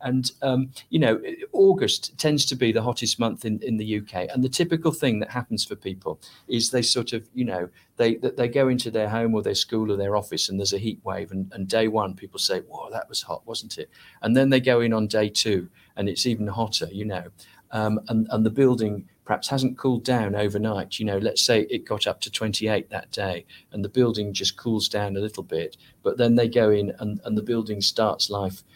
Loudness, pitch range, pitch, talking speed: -24 LUFS, 105-125 Hz, 110 Hz, 235 wpm